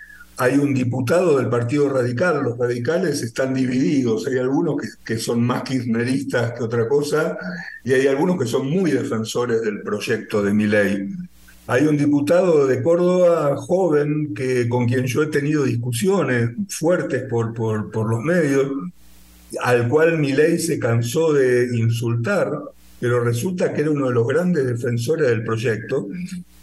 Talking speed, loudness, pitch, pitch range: 160 wpm, -20 LUFS, 130 Hz, 120-150 Hz